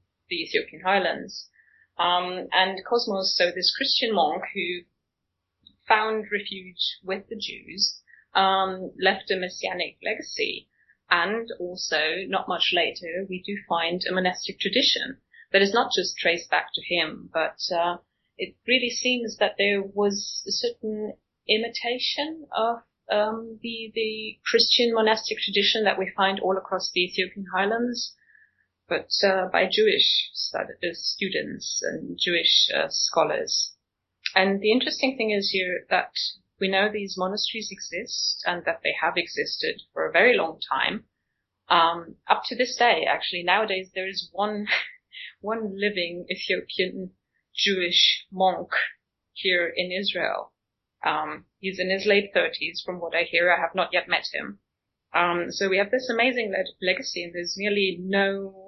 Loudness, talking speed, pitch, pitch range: -24 LUFS, 145 wpm, 195 Hz, 185-225 Hz